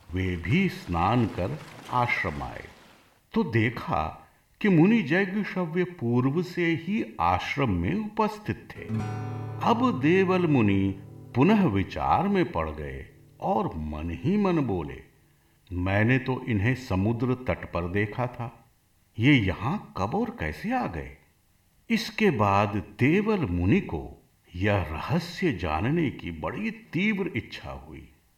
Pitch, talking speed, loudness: 125 Hz, 125 wpm, -26 LUFS